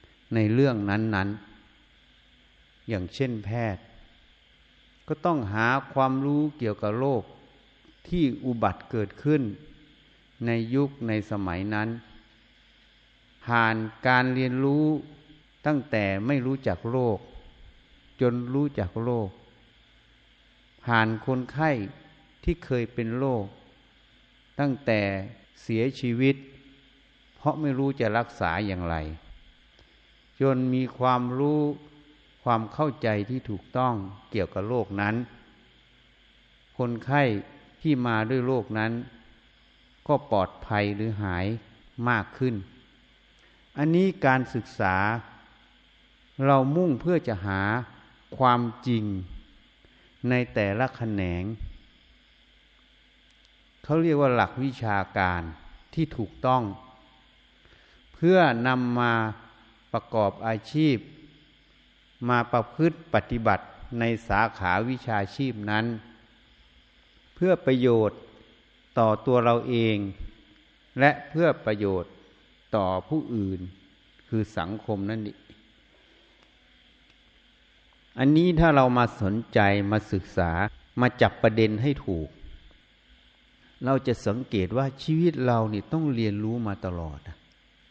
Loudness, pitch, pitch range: -26 LUFS, 115 Hz, 100-130 Hz